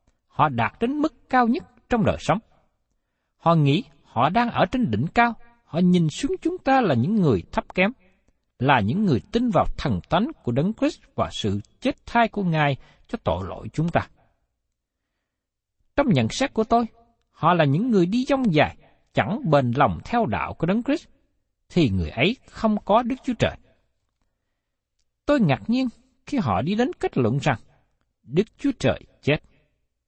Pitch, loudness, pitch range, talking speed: 220 Hz, -23 LUFS, 155-250 Hz, 180 wpm